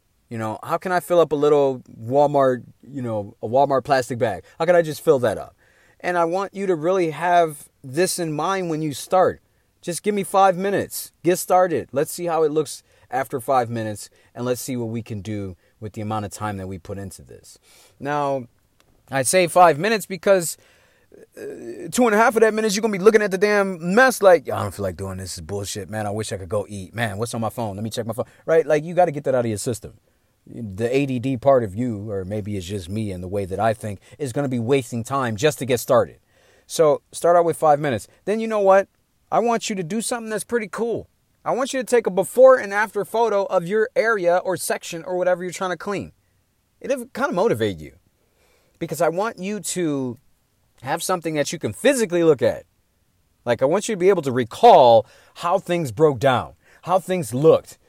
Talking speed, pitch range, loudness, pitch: 235 wpm, 115-190 Hz, -21 LUFS, 150 Hz